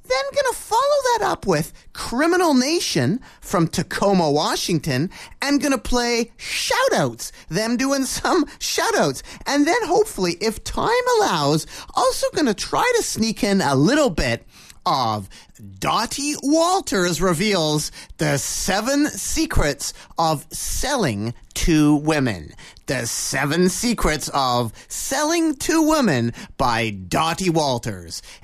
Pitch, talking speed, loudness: 200 Hz, 120 wpm, -20 LUFS